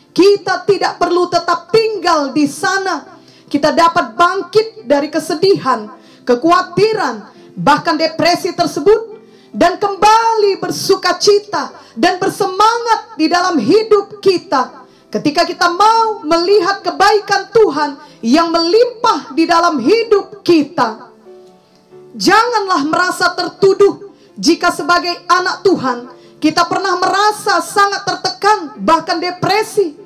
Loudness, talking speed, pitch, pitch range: -13 LUFS, 105 wpm, 360 Hz, 330-400 Hz